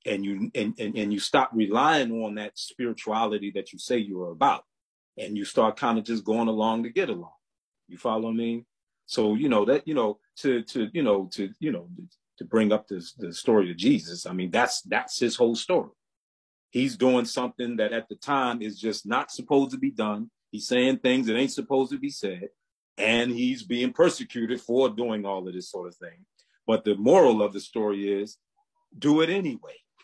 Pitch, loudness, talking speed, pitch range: 115 Hz, -26 LUFS, 210 wpm, 105-130 Hz